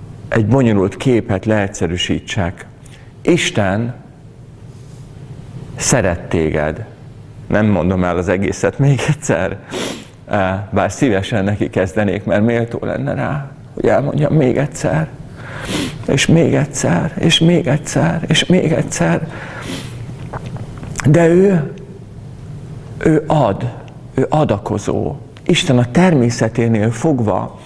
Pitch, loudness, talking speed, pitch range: 130 Hz, -16 LUFS, 100 wpm, 110-145 Hz